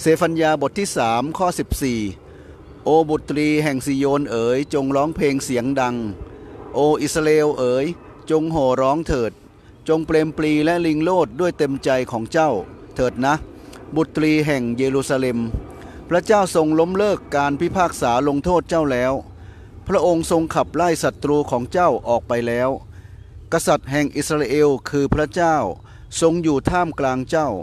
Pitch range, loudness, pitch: 125-160 Hz, -19 LUFS, 145 Hz